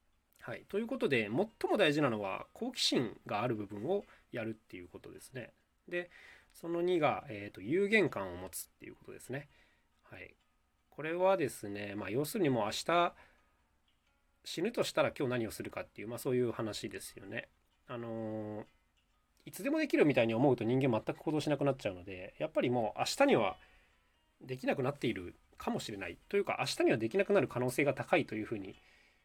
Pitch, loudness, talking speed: 115 Hz, -35 LUFS, 385 characters per minute